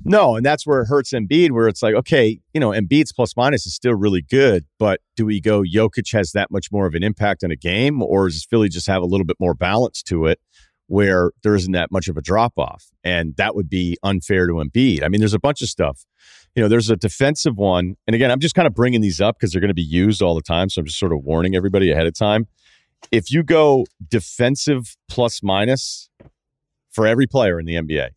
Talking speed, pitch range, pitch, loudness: 245 wpm, 90-120 Hz, 105 Hz, -18 LUFS